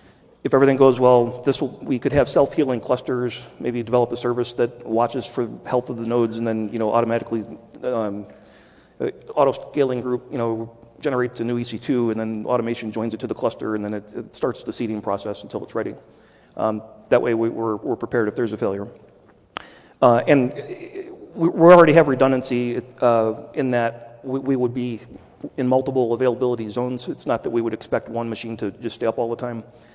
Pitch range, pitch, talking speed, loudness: 115-125 Hz, 120 Hz, 200 wpm, -21 LUFS